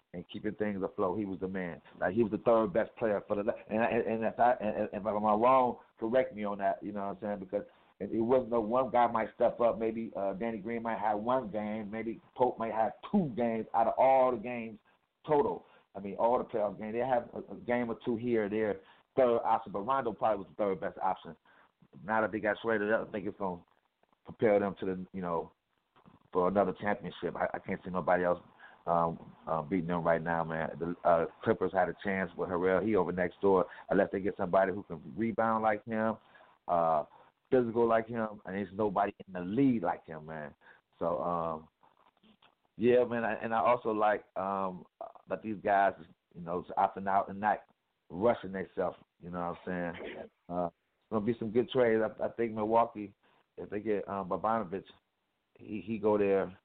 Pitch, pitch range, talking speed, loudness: 105 Hz, 95-115 Hz, 215 wpm, -32 LUFS